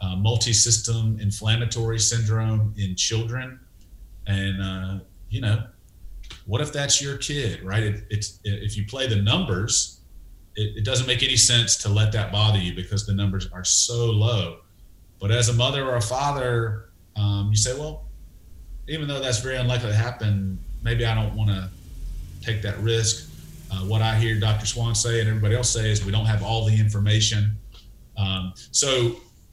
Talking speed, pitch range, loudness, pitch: 175 wpm, 95-115 Hz, -23 LUFS, 105 Hz